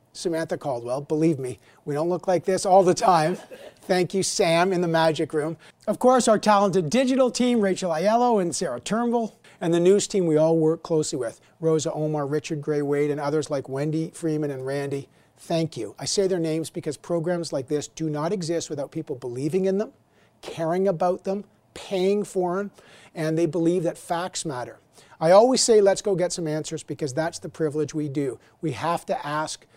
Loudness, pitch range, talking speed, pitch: -24 LUFS, 155-190 Hz, 200 wpm, 165 Hz